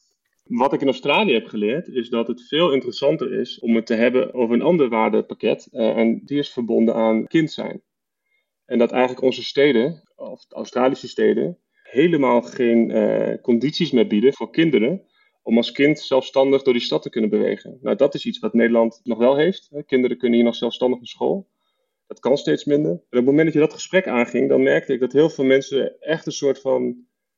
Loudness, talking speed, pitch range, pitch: -20 LUFS, 205 wpm, 120-145 Hz, 125 Hz